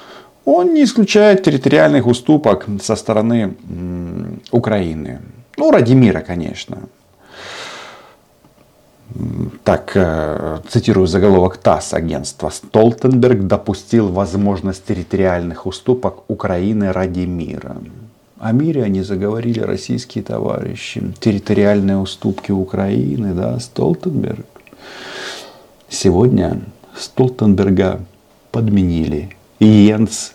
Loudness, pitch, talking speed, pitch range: -15 LUFS, 105 Hz, 80 wpm, 95-115 Hz